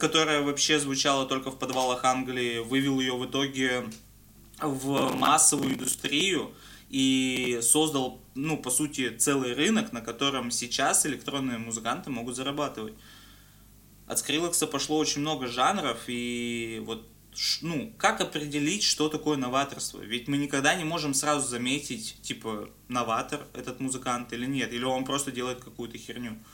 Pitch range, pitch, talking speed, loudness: 120-145 Hz, 130 Hz, 140 wpm, -27 LUFS